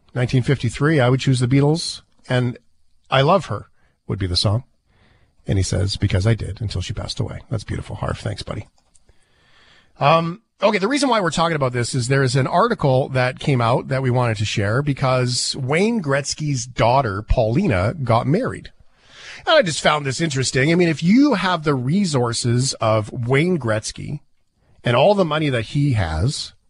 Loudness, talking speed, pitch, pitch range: -19 LUFS, 180 wpm, 130 Hz, 115-150 Hz